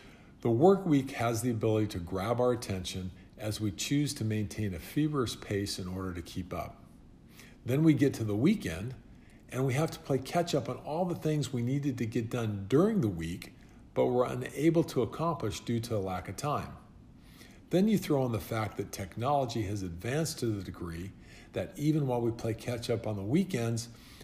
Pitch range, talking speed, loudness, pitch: 100-140 Hz, 205 wpm, -32 LUFS, 115 Hz